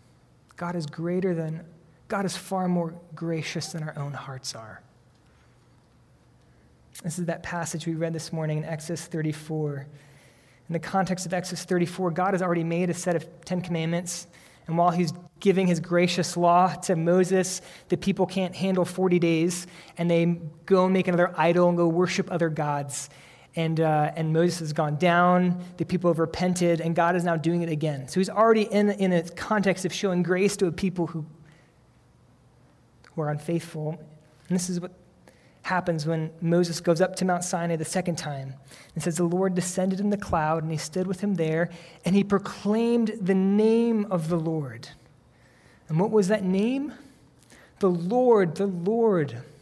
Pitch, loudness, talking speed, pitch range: 170 Hz, -26 LUFS, 180 wpm, 160-185 Hz